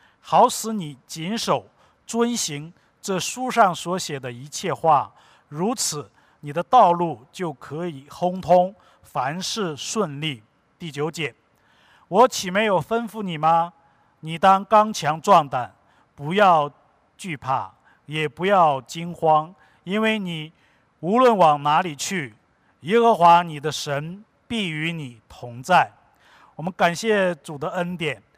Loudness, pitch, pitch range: -21 LUFS, 170 Hz, 150-195 Hz